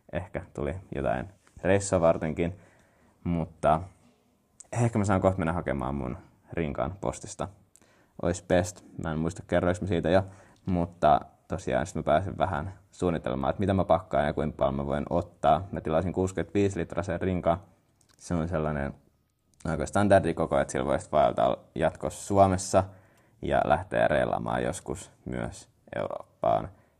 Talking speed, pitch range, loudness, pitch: 140 wpm, 80-95 Hz, -28 LUFS, 85 Hz